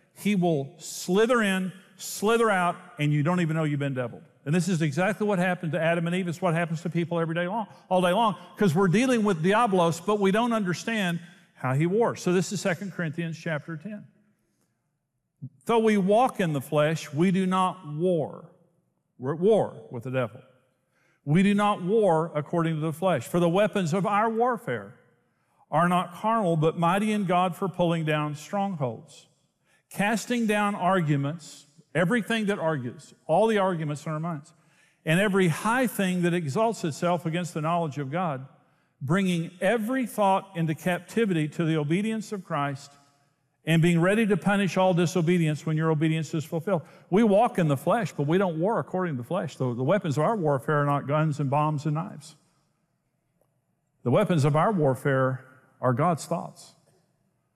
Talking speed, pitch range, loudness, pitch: 180 wpm, 155-195 Hz, -26 LUFS, 175 Hz